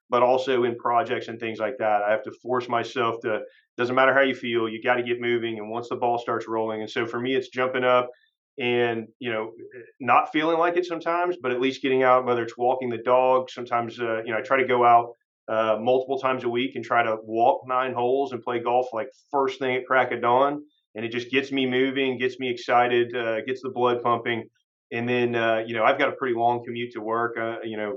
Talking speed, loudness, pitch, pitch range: 245 wpm, -24 LUFS, 120 Hz, 115-130 Hz